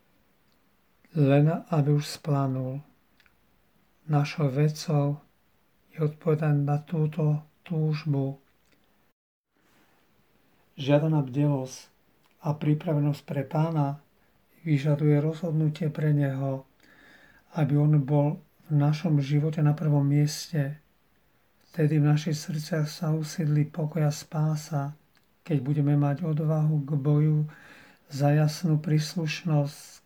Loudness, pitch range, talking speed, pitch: -27 LUFS, 145-155 Hz, 95 wpm, 150 Hz